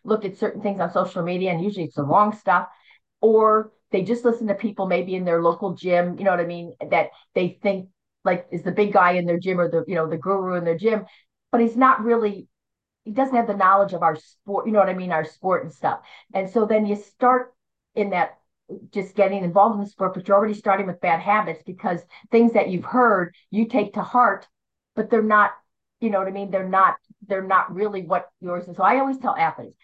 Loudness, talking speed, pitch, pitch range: -22 LUFS, 240 wpm, 195 Hz, 180-215 Hz